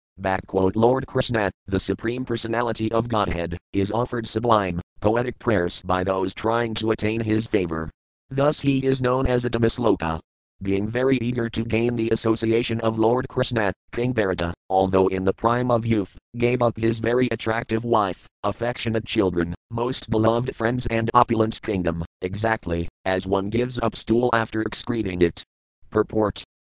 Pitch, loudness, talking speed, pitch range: 110 Hz, -23 LUFS, 160 wpm, 95-120 Hz